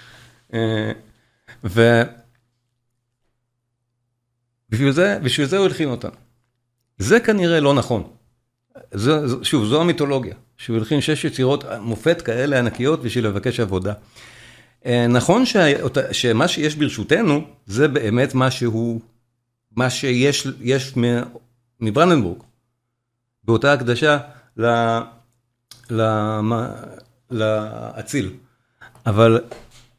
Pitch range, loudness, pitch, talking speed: 115-135 Hz, -19 LUFS, 120 Hz, 90 wpm